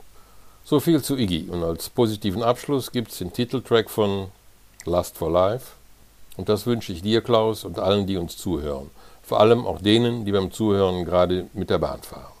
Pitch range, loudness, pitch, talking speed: 95-115 Hz, -23 LUFS, 105 Hz, 190 wpm